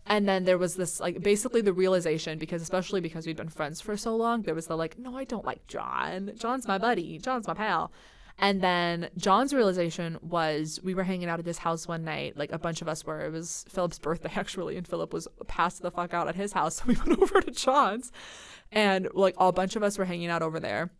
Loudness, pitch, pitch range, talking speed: -29 LUFS, 185 Hz, 165-210 Hz, 245 wpm